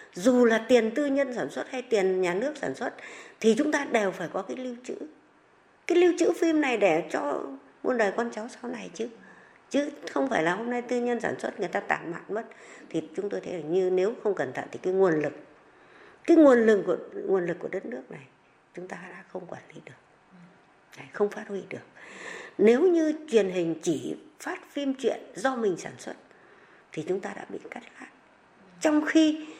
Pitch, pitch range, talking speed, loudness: 230 Hz, 185-290 Hz, 215 wpm, -27 LUFS